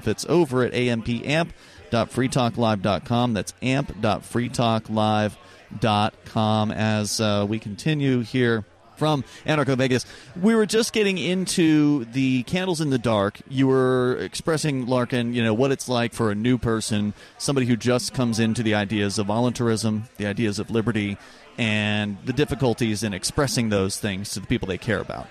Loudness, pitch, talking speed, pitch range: -23 LUFS, 120 Hz, 150 wpm, 105-130 Hz